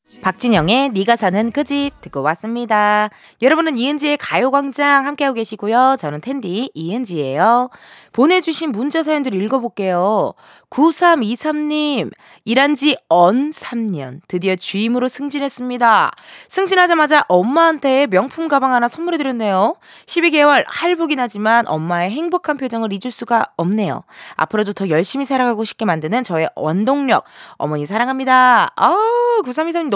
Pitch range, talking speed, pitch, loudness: 210-295 Hz, 315 characters per minute, 250 Hz, -16 LUFS